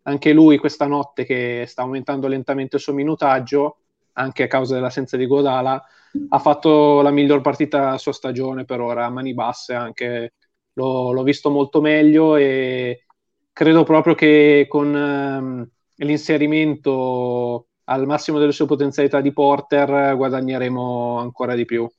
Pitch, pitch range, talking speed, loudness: 140 Hz, 130-145 Hz, 145 wpm, -18 LUFS